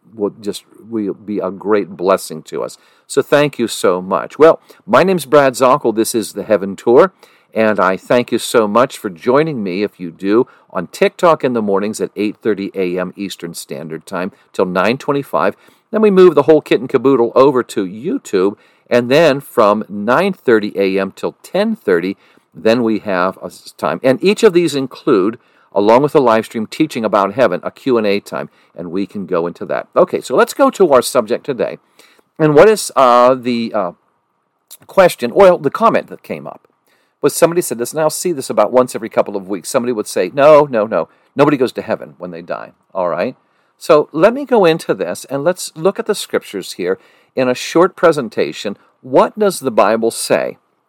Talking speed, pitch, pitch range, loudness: 195 wpm, 125 Hz, 105-170 Hz, -14 LUFS